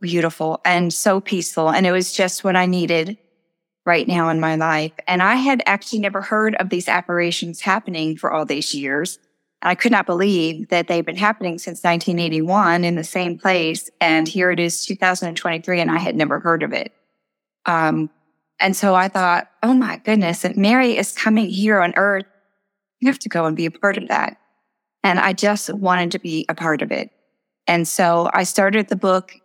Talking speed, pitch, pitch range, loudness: 200 wpm, 180 Hz, 165-200 Hz, -18 LUFS